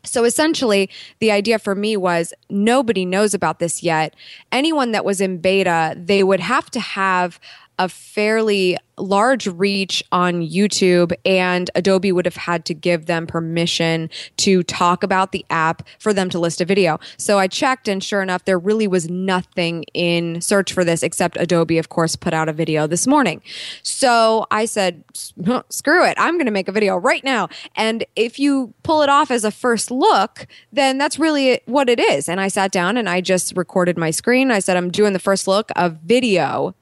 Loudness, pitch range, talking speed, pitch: -18 LUFS, 175-220 Hz, 195 wpm, 195 Hz